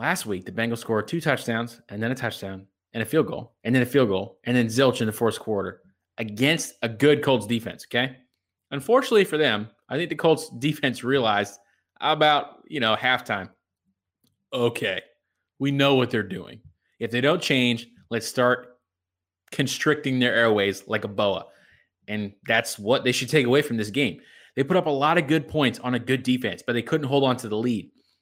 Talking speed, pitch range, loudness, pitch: 200 wpm, 115-140 Hz, -24 LUFS, 125 Hz